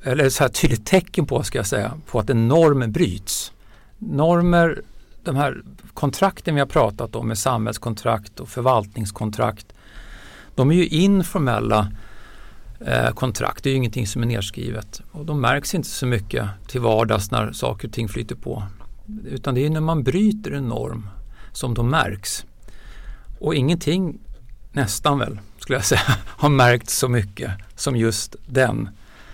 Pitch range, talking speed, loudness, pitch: 110-140 Hz, 160 wpm, -21 LUFS, 120 Hz